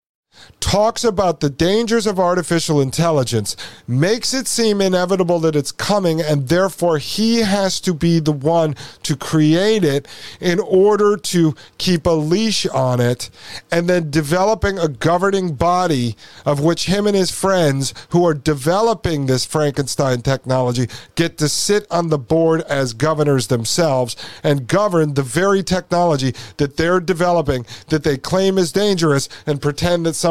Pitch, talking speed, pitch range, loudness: 165 Hz, 150 wpm, 145-185 Hz, -17 LUFS